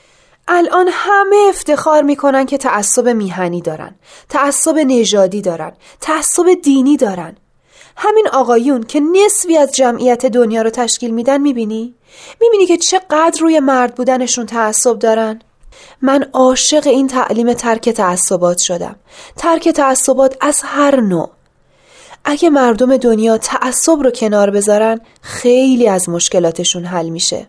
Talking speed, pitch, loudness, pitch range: 125 wpm, 255 Hz, -12 LUFS, 225-300 Hz